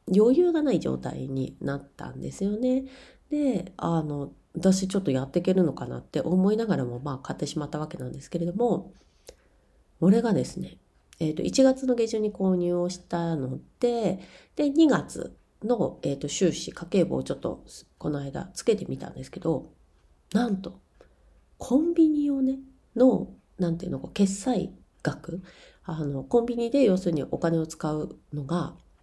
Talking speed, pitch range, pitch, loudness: 310 characters per minute, 150-240 Hz, 180 Hz, -27 LUFS